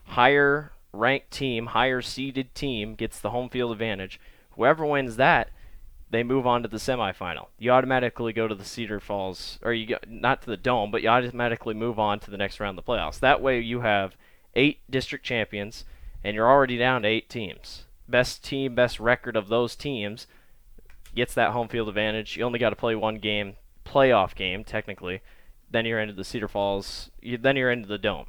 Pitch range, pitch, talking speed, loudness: 105-125 Hz, 115 Hz, 200 wpm, -25 LUFS